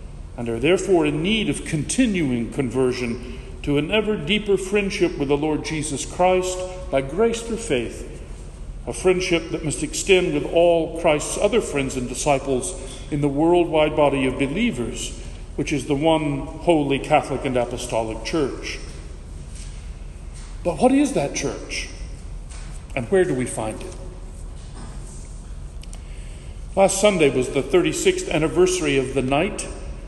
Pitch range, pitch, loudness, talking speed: 120-180 Hz, 145 Hz, -21 LUFS, 140 wpm